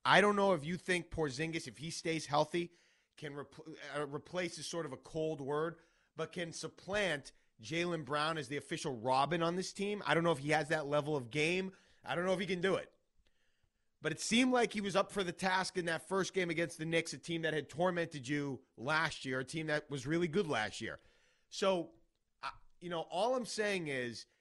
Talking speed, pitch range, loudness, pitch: 225 wpm, 150-180 Hz, -36 LUFS, 160 Hz